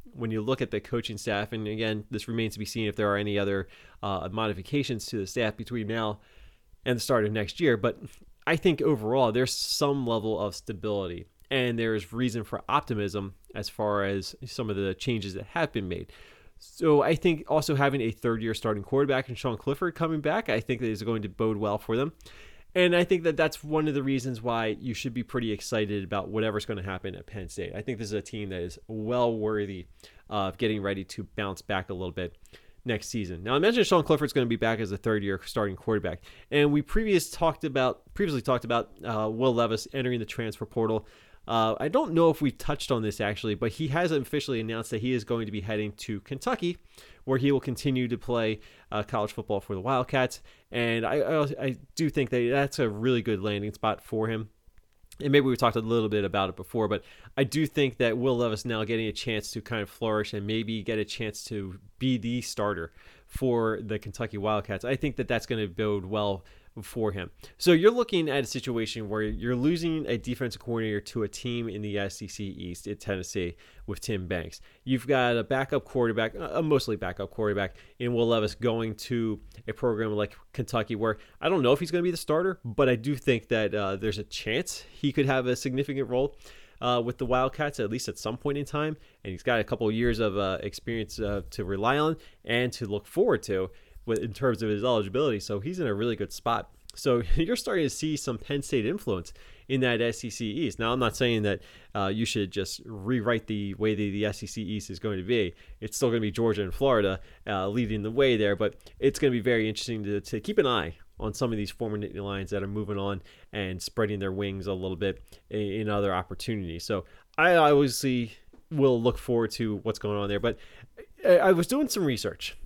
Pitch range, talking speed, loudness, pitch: 105-130 Hz, 225 wpm, -28 LUFS, 110 Hz